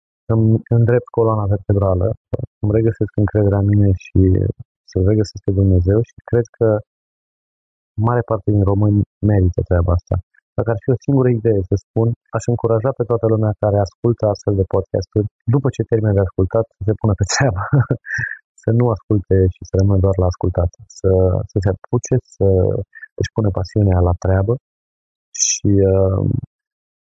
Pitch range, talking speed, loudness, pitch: 95-115 Hz, 160 wpm, -17 LUFS, 105 Hz